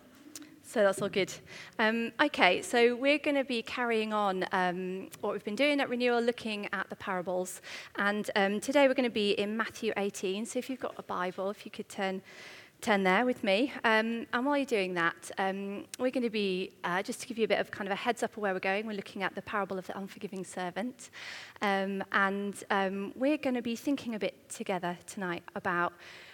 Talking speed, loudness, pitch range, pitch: 225 wpm, -31 LUFS, 195-245 Hz, 205 Hz